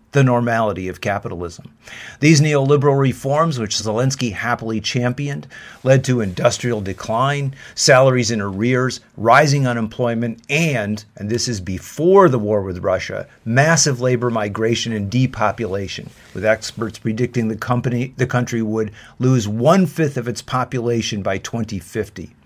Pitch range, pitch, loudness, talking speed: 110-130 Hz, 120 Hz, -18 LUFS, 135 wpm